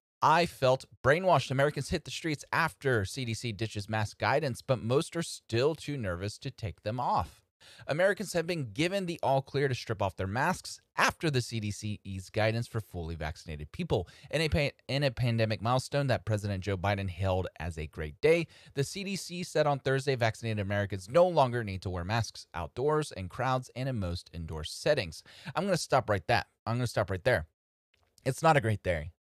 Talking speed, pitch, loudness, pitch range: 200 wpm, 115 Hz, -31 LUFS, 100-140 Hz